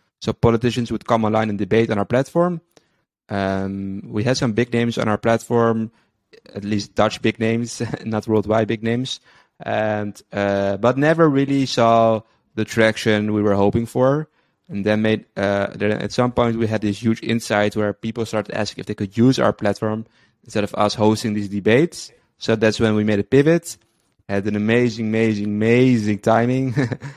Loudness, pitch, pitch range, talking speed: -20 LUFS, 110 Hz, 105-120 Hz, 180 wpm